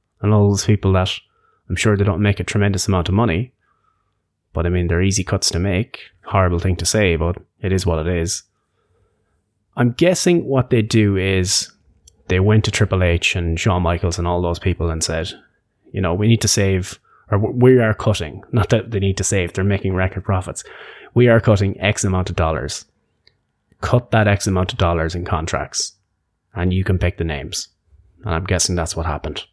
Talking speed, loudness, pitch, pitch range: 205 wpm, -18 LUFS, 95 Hz, 85-105 Hz